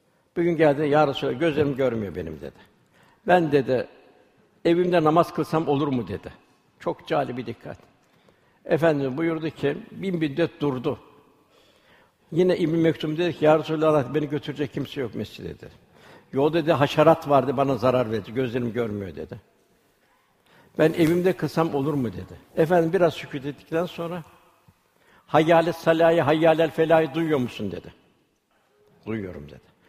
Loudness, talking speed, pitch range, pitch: -23 LUFS, 145 wpm, 140-165 Hz, 155 Hz